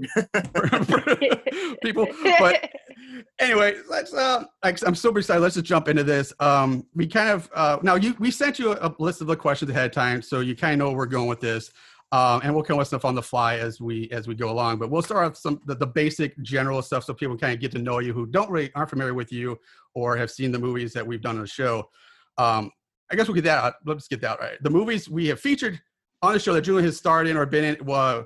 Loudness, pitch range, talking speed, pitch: -23 LUFS, 125-185 Hz, 260 wpm, 150 Hz